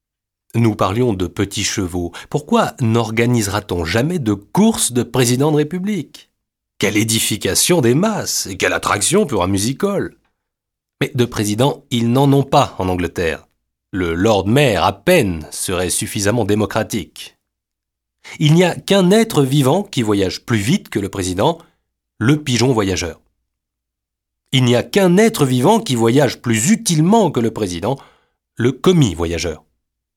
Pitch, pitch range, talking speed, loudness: 115 Hz, 100-145 Hz, 145 wpm, -16 LUFS